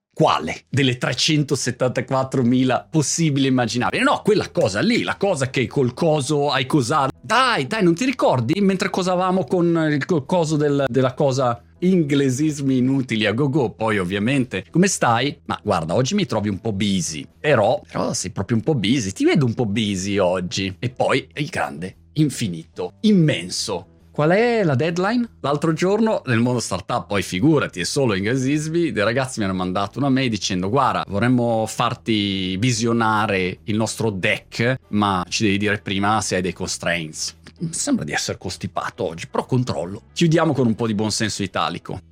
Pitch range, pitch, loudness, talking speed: 105-155 Hz, 130 Hz, -20 LUFS, 170 wpm